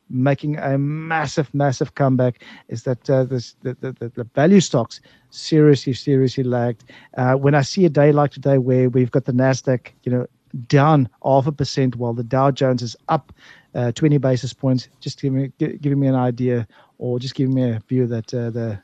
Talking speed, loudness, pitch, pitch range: 195 wpm, -19 LUFS, 130 Hz, 125-140 Hz